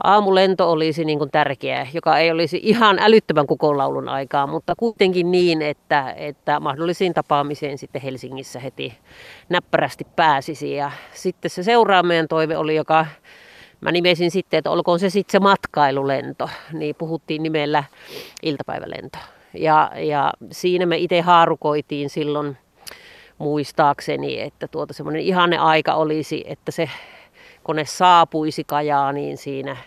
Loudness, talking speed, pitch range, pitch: -19 LUFS, 135 wpm, 145-175 Hz, 160 Hz